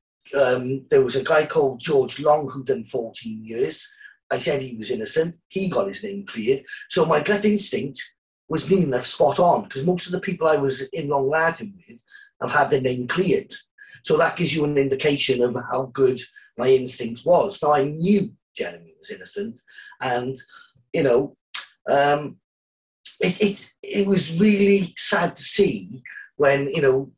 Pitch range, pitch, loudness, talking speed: 135-205 Hz, 170 Hz, -22 LUFS, 175 wpm